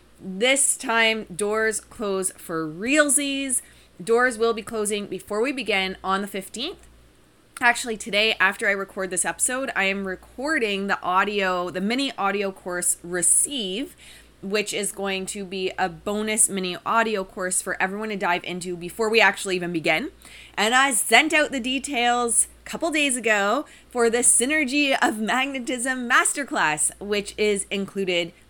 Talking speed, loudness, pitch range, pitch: 150 wpm, -22 LUFS, 190-245 Hz, 210 Hz